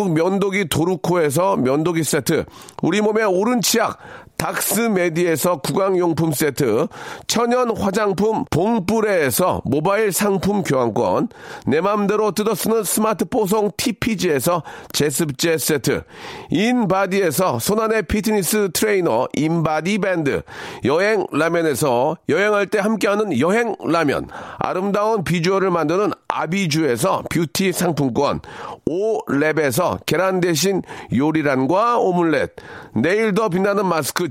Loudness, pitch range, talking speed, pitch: -19 LUFS, 165-215 Hz, 275 characters per minute, 190 Hz